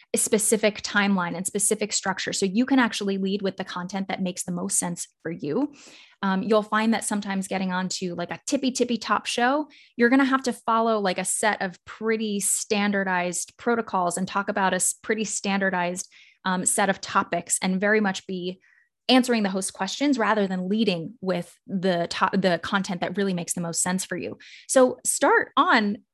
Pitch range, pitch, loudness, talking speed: 185-225 Hz, 200 Hz, -24 LUFS, 190 wpm